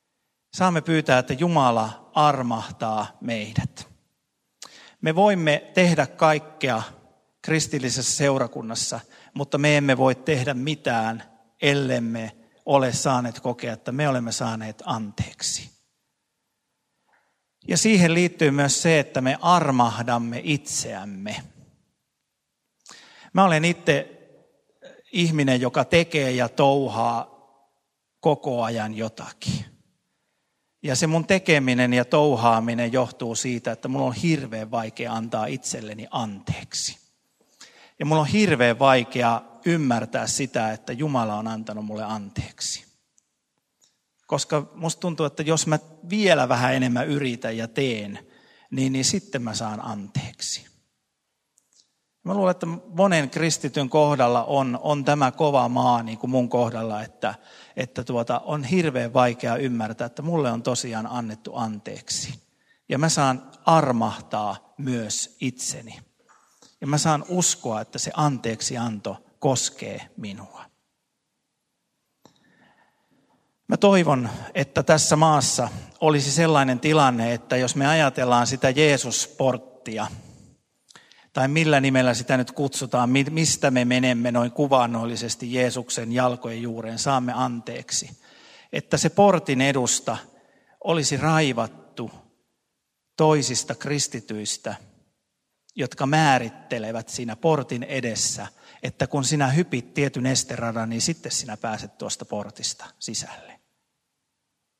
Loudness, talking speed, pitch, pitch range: -23 LUFS, 110 wpm, 130 Hz, 115-150 Hz